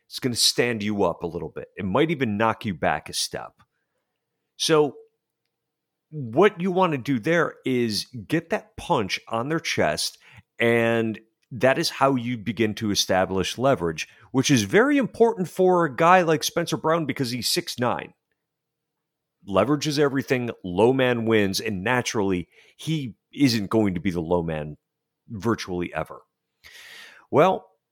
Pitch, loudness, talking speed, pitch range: 130 Hz, -23 LUFS, 155 wpm, 110-155 Hz